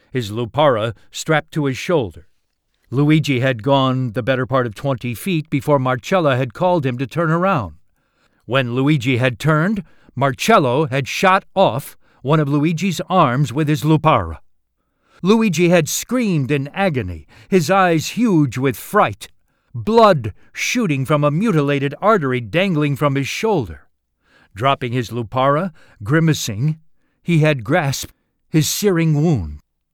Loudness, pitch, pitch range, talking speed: -17 LUFS, 145 Hz, 130-170 Hz, 135 wpm